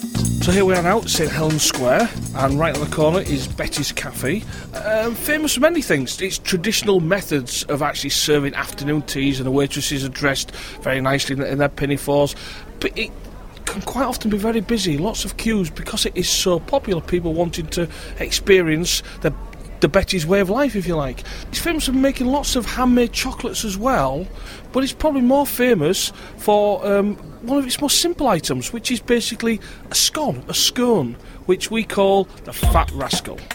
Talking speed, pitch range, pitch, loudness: 185 wpm, 145-235 Hz, 190 Hz, -19 LUFS